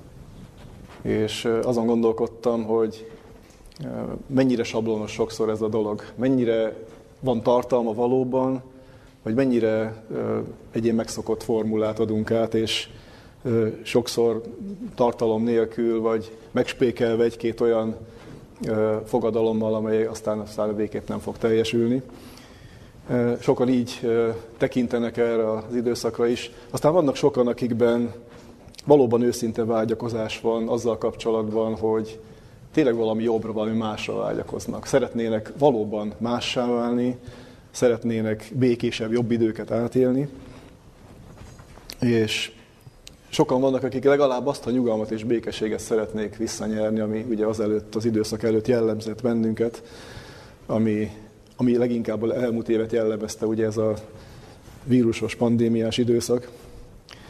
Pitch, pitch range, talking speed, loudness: 115 Hz, 110-120 Hz, 110 wpm, -24 LUFS